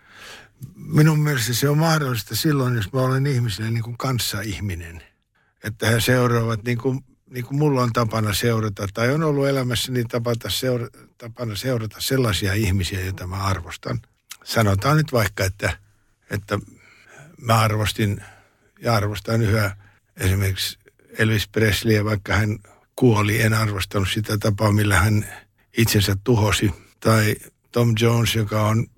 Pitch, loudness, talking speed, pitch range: 110 Hz, -21 LUFS, 135 wpm, 105-120 Hz